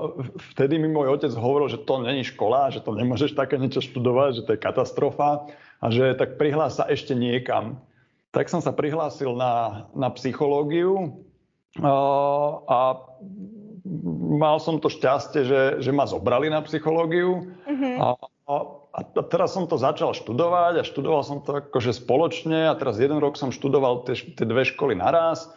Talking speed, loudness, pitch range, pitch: 165 wpm, -23 LUFS, 130-160 Hz, 145 Hz